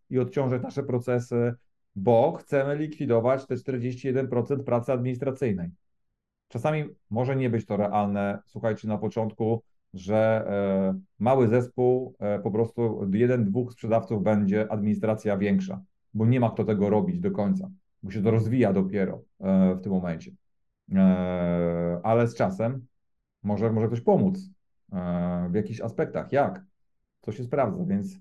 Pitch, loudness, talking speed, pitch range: 115 Hz, -26 LUFS, 130 wpm, 100-125 Hz